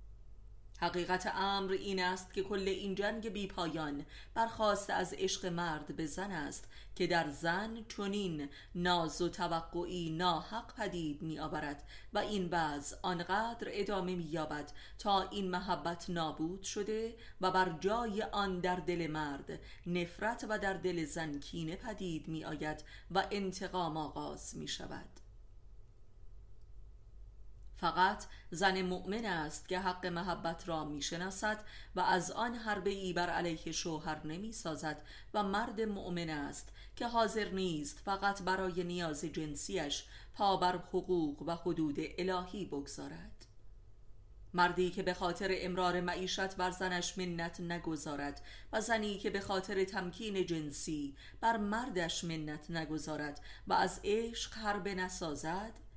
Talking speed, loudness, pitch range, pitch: 130 wpm, -37 LUFS, 155-195 Hz, 175 Hz